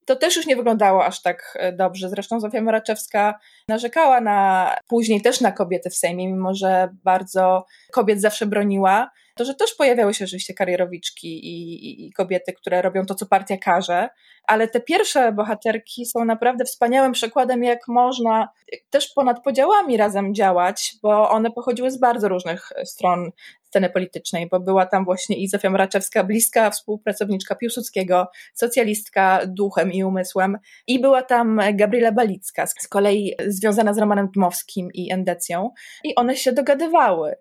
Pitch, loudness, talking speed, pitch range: 210 Hz, -20 LUFS, 150 wpm, 185-240 Hz